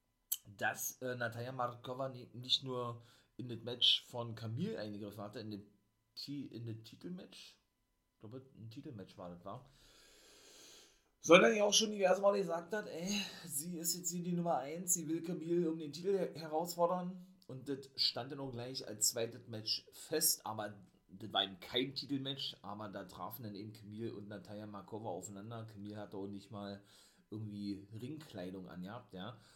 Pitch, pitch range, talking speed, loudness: 120 Hz, 105-160 Hz, 165 wpm, -38 LUFS